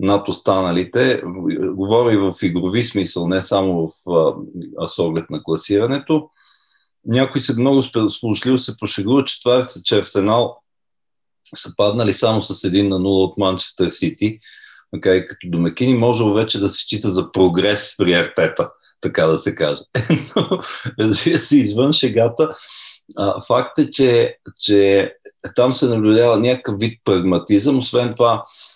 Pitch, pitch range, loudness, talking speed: 115 Hz, 100-130 Hz, -17 LUFS, 140 wpm